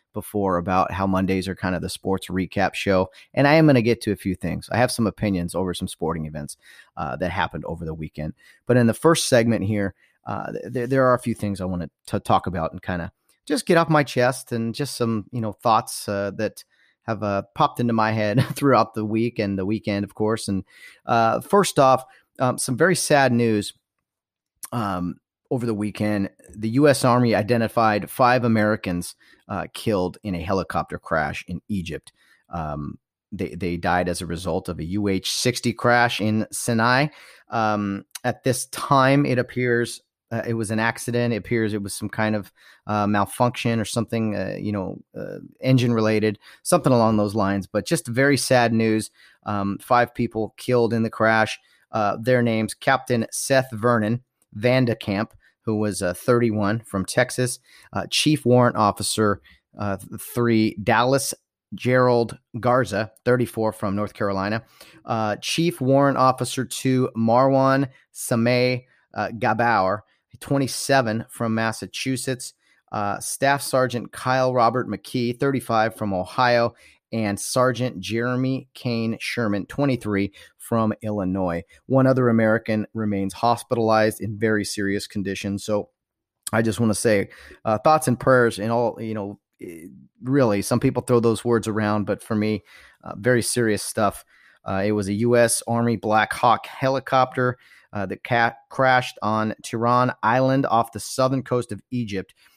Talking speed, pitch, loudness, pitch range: 165 wpm, 115 Hz, -22 LUFS, 100-125 Hz